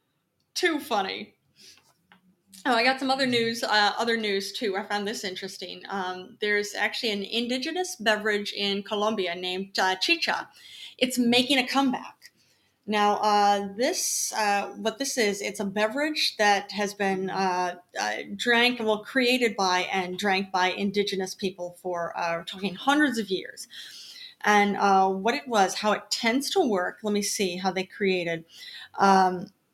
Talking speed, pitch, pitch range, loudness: 160 wpm, 205 Hz, 190-235 Hz, -25 LUFS